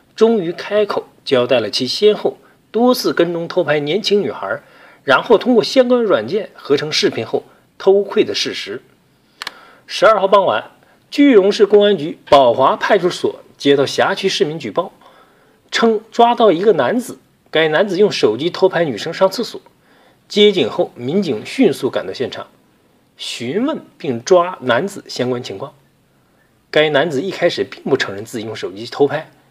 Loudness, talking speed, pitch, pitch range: -16 LUFS, 245 characters per minute, 200 Hz, 170-230 Hz